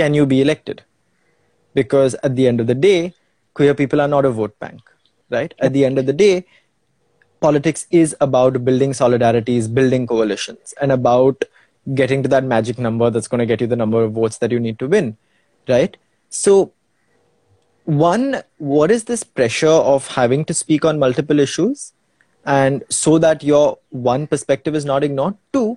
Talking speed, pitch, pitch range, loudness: 180 wpm, 135 Hz, 125-155 Hz, -16 LUFS